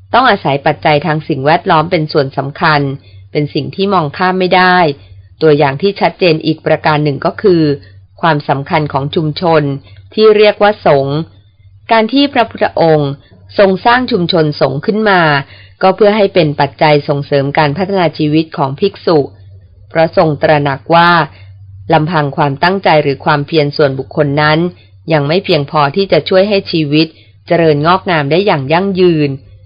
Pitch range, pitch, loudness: 140-180 Hz, 155 Hz, -11 LUFS